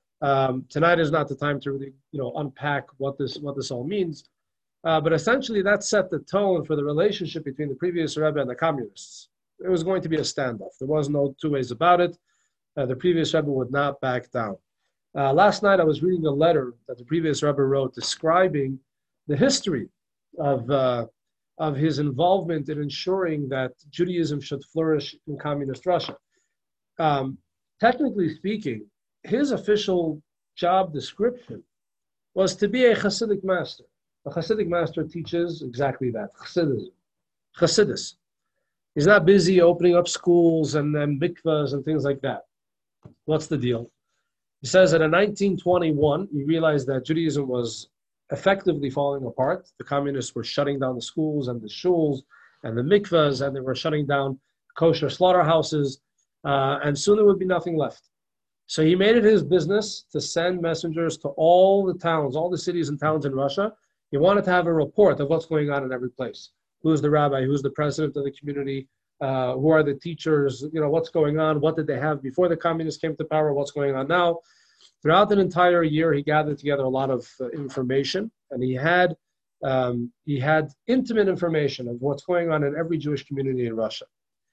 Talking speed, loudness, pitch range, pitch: 185 wpm, -23 LUFS, 140-175 Hz, 155 Hz